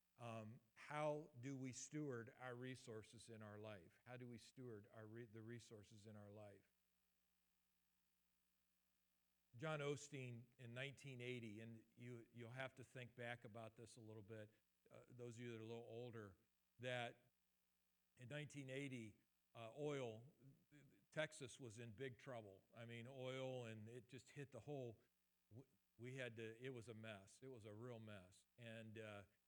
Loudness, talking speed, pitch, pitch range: -56 LUFS, 165 wpm, 115 Hz, 105-130 Hz